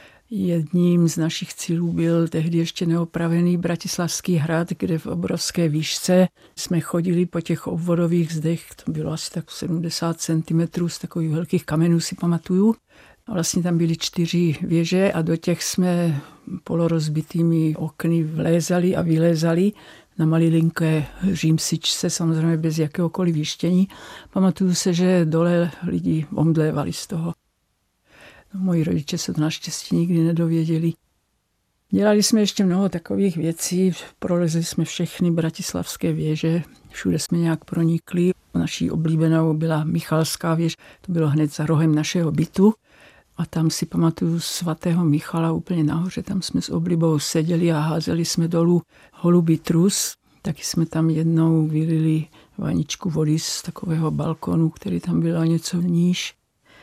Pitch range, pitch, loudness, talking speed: 160-175 Hz, 165 Hz, -21 LUFS, 140 wpm